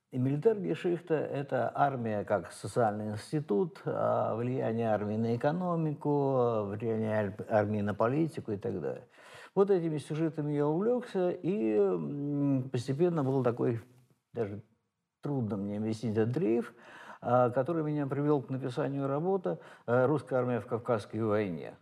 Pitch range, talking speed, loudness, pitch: 110-150 Hz, 125 wpm, -32 LUFS, 130 Hz